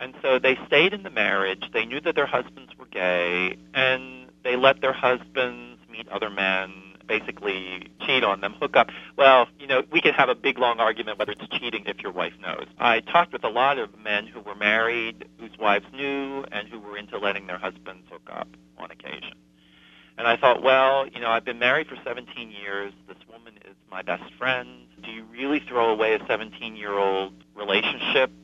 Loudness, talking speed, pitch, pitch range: -23 LUFS, 200 wpm, 105 Hz, 90-120 Hz